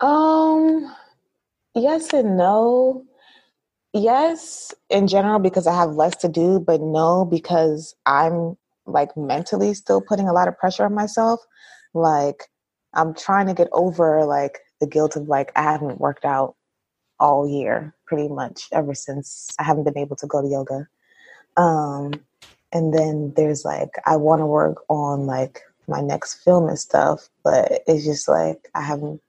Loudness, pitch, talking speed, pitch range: -20 LUFS, 160 Hz, 160 wpm, 150-200 Hz